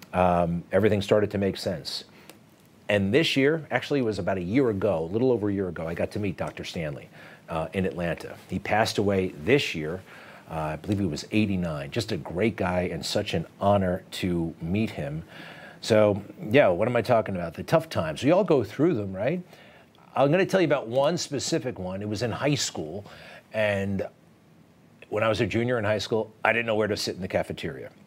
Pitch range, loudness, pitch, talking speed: 95-120 Hz, -26 LUFS, 105 Hz, 215 wpm